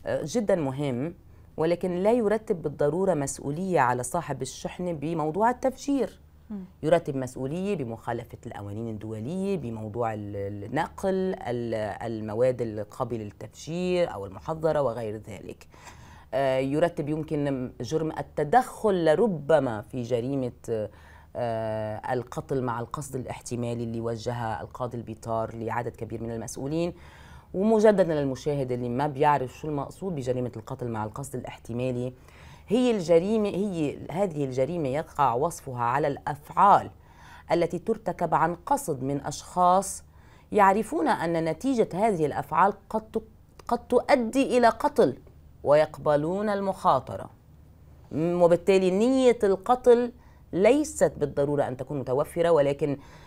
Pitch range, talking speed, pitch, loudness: 120-185 Hz, 105 wpm, 145 Hz, -27 LUFS